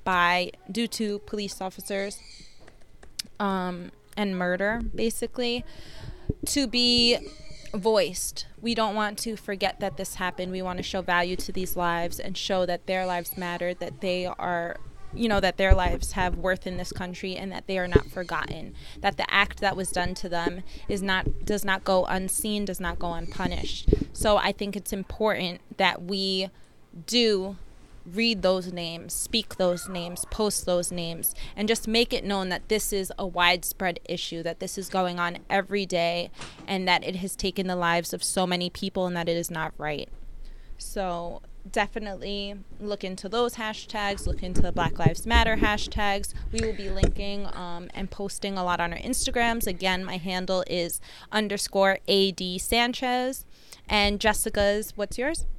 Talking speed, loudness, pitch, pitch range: 170 wpm, -27 LUFS, 190 Hz, 180-210 Hz